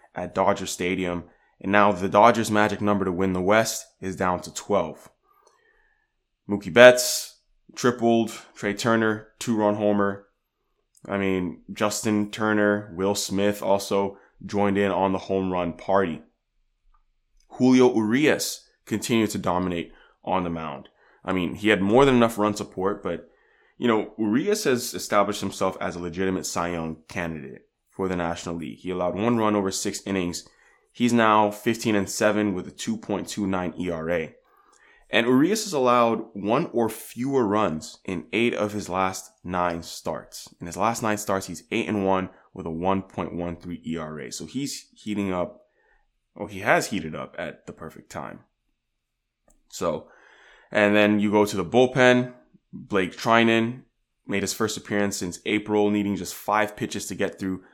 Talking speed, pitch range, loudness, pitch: 160 wpm, 95-110 Hz, -24 LUFS, 100 Hz